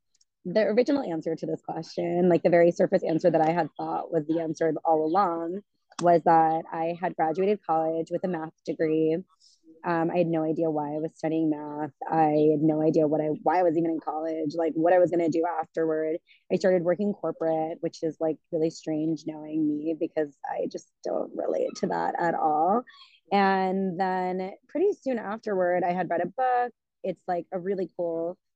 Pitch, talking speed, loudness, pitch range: 165 Hz, 200 wpm, -26 LUFS, 160-185 Hz